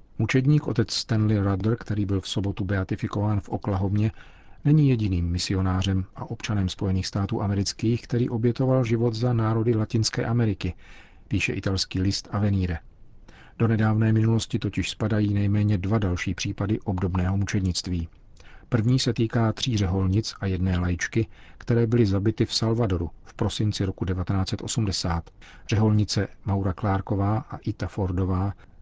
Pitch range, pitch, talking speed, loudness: 95-115 Hz, 105 Hz, 135 wpm, -25 LUFS